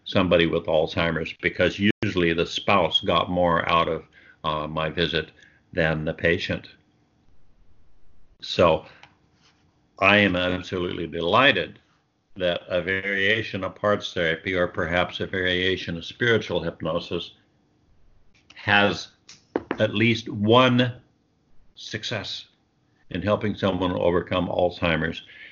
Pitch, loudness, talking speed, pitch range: 90 Hz, -23 LUFS, 105 wpm, 85-105 Hz